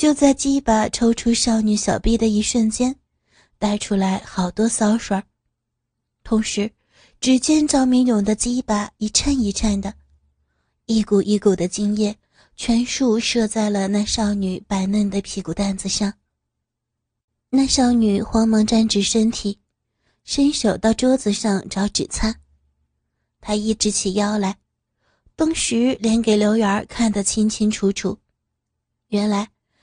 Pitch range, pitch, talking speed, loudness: 195-230 Hz, 210 Hz, 195 characters per minute, -19 LUFS